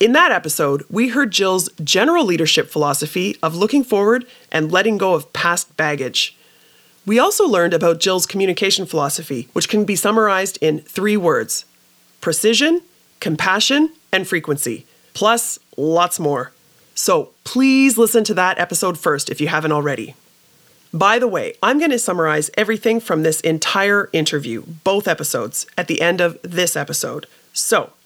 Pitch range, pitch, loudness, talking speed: 160-215 Hz, 180 Hz, -17 LUFS, 150 wpm